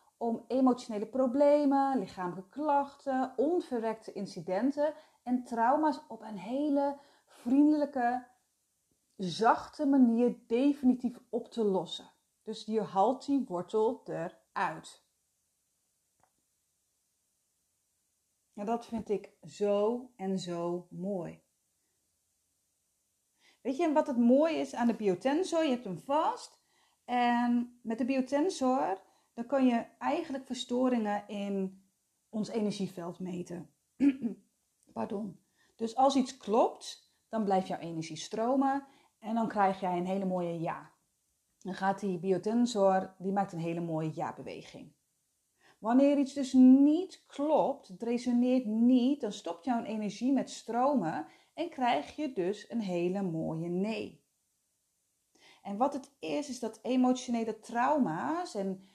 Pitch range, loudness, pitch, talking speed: 195-270 Hz, -31 LUFS, 235 Hz, 120 wpm